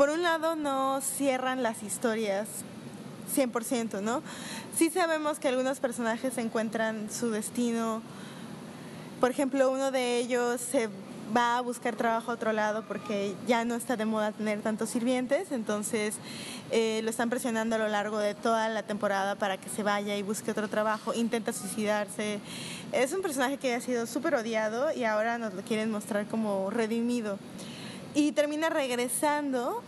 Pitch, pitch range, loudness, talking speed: 230 Hz, 215-255 Hz, -30 LUFS, 160 wpm